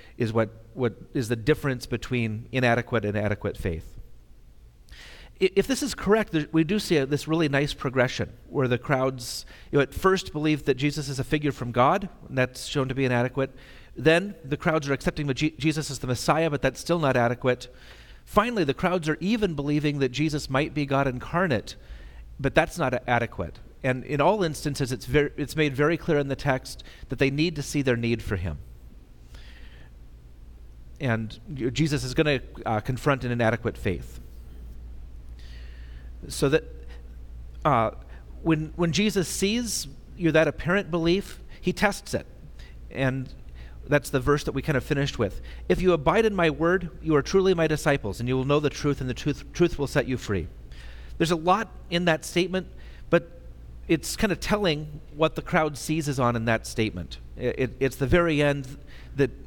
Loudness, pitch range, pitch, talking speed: -26 LUFS, 110-155 Hz, 135 Hz, 185 wpm